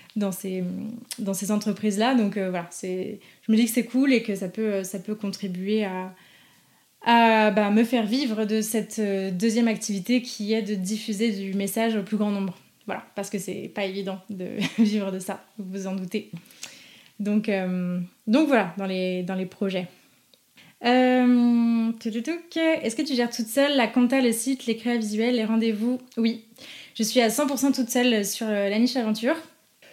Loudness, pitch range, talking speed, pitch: -24 LUFS, 195-240 Hz, 185 wpm, 220 Hz